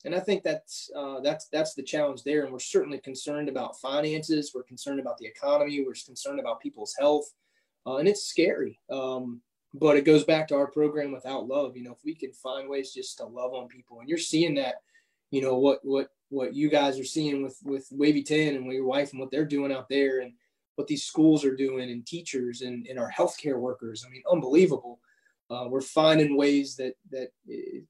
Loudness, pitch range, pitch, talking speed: -28 LUFS, 130-155 Hz, 140 Hz, 215 wpm